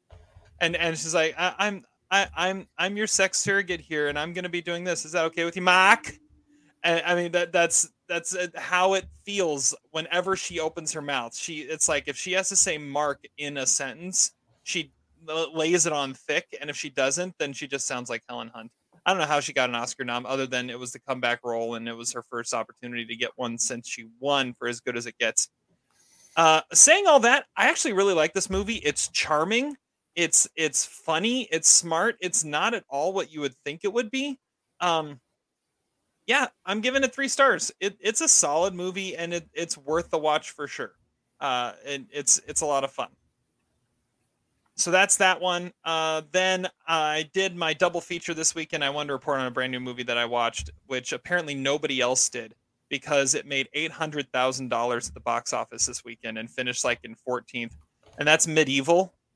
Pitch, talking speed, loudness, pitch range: 160 Hz, 210 wpm, -25 LUFS, 130-180 Hz